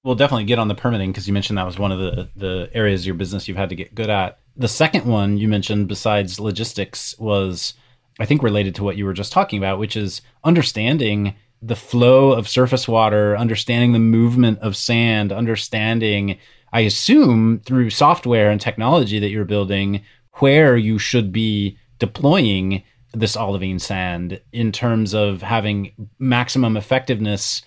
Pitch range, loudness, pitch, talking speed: 100-120 Hz, -18 LUFS, 110 Hz, 175 wpm